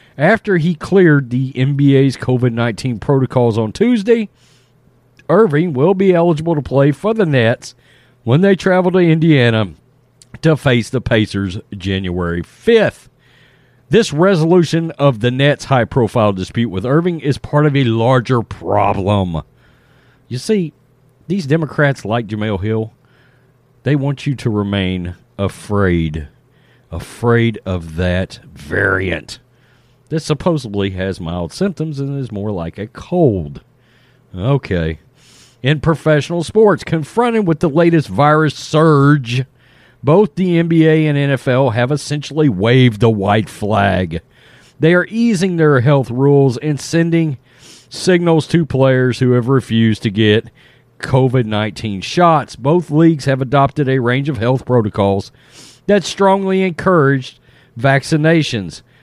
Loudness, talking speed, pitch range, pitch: -15 LUFS, 130 wpm, 115-155 Hz, 130 Hz